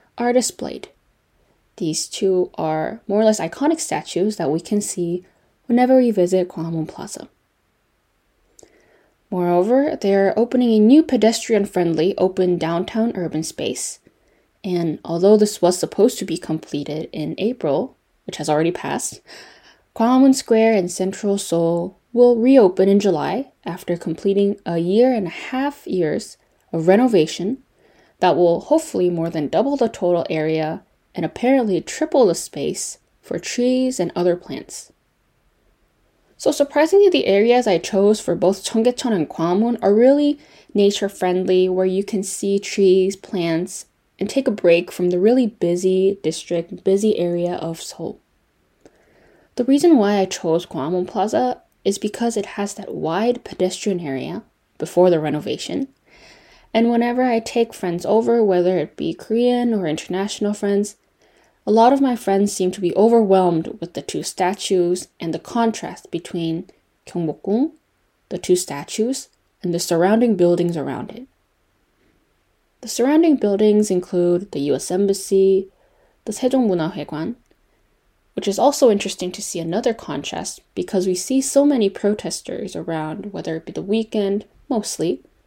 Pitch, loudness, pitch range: 195 Hz, -19 LUFS, 175-230 Hz